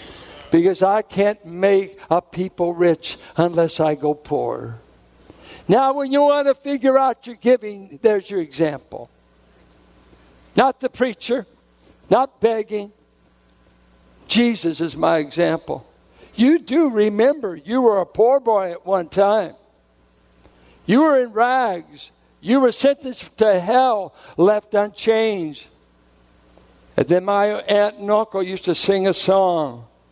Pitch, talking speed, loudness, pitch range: 195 Hz, 130 wpm, -19 LUFS, 145-230 Hz